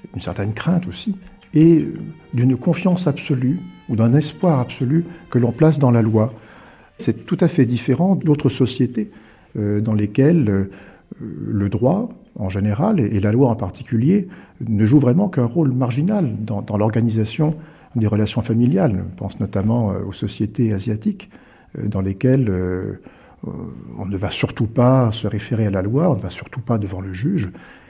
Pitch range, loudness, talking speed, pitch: 105-155 Hz, -19 LUFS, 170 wpm, 120 Hz